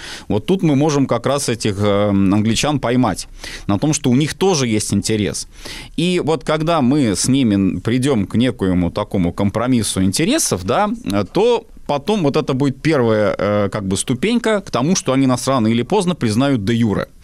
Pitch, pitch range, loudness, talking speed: 125 Hz, 105-155 Hz, -17 LUFS, 175 wpm